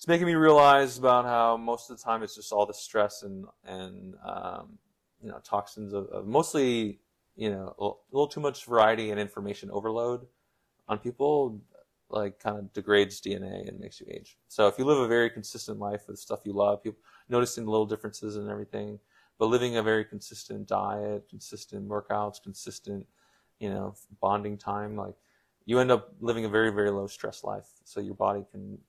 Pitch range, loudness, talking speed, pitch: 105-120 Hz, -28 LUFS, 190 wpm, 105 Hz